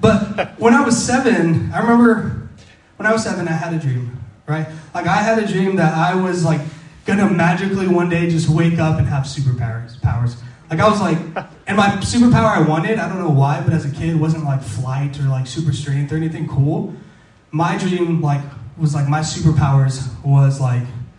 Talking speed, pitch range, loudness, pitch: 205 wpm, 140-185 Hz, -17 LUFS, 155 Hz